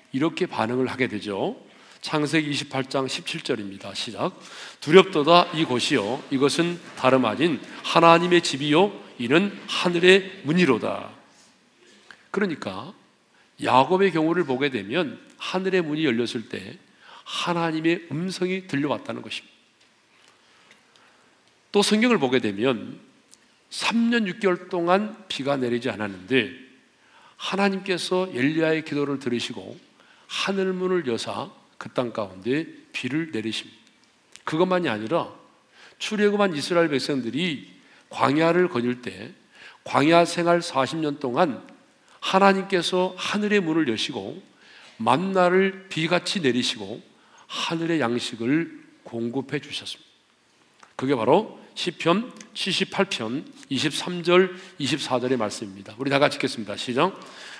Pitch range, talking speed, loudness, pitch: 130-185 Hz, 250 characters per minute, -23 LUFS, 160 Hz